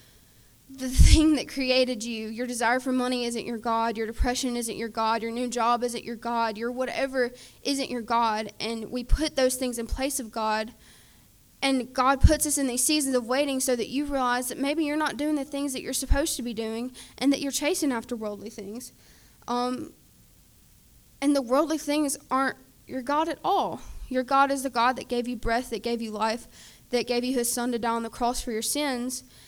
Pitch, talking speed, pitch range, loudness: 250 Hz, 215 wpm, 230-270 Hz, -27 LUFS